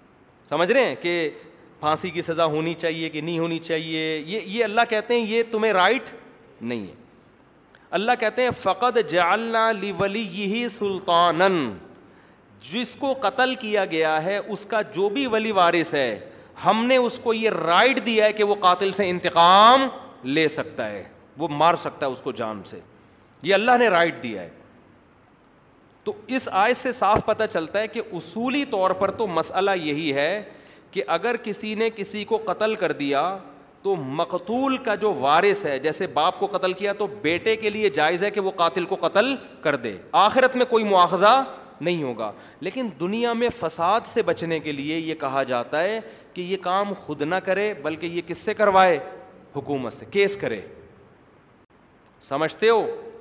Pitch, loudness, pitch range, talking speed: 190 Hz, -22 LUFS, 160-220 Hz, 180 wpm